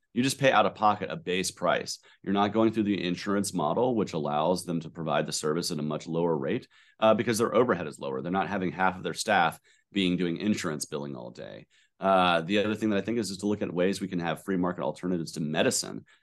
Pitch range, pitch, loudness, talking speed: 85-105 Hz, 95 Hz, -28 LUFS, 250 wpm